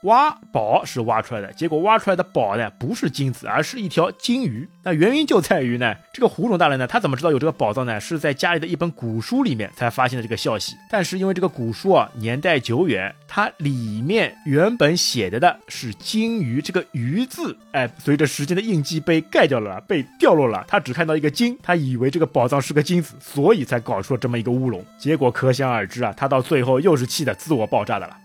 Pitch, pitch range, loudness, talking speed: 150 Hz, 125-180 Hz, -20 LUFS, 350 characters per minute